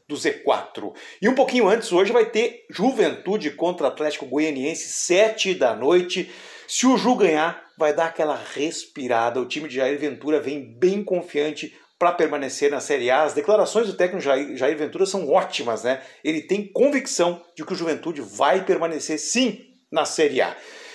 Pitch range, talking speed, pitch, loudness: 150-225 Hz, 165 wpm, 175 Hz, -22 LUFS